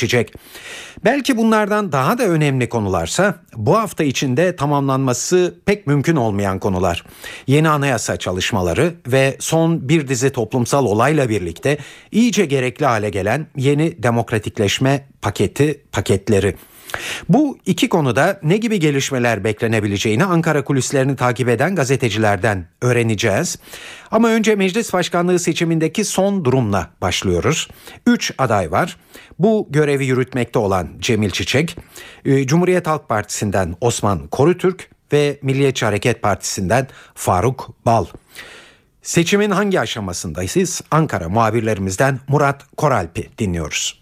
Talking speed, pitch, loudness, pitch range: 110 wpm, 135 Hz, -17 LUFS, 110-165 Hz